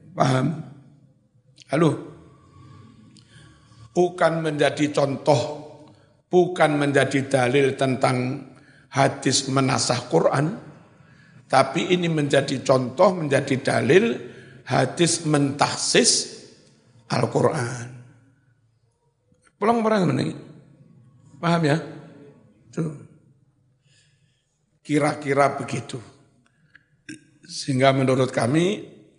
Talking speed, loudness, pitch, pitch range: 65 wpm, -22 LUFS, 140 Hz, 130-150 Hz